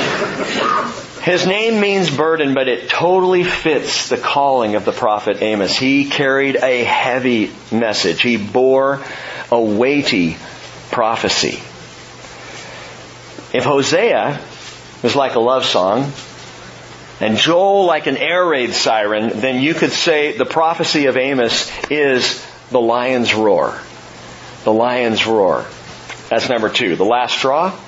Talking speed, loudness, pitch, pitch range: 125 wpm, -15 LUFS, 130 Hz, 115-160 Hz